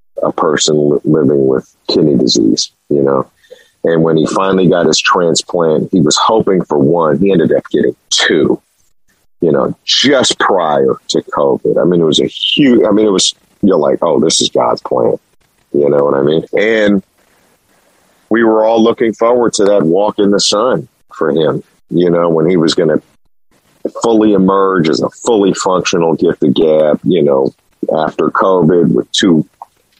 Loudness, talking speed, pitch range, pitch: -11 LUFS, 175 wpm, 75-105 Hz, 90 Hz